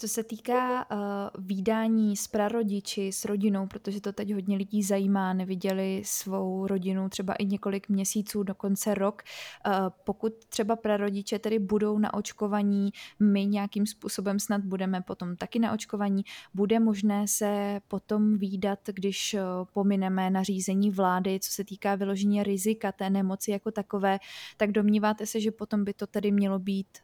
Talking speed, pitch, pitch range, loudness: 150 wpm, 205 Hz, 195-210 Hz, -29 LUFS